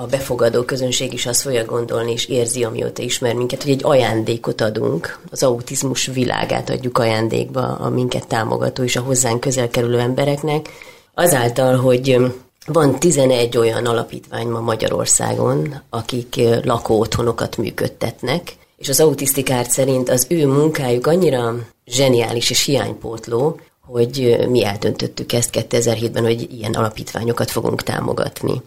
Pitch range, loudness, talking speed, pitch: 115-135 Hz, -18 LUFS, 130 wpm, 125 Hz